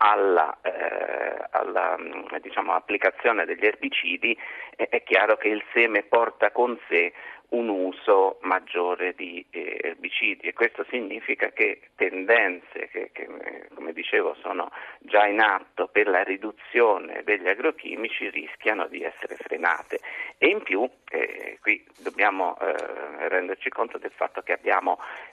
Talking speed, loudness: 135 wpm, -25 LUFS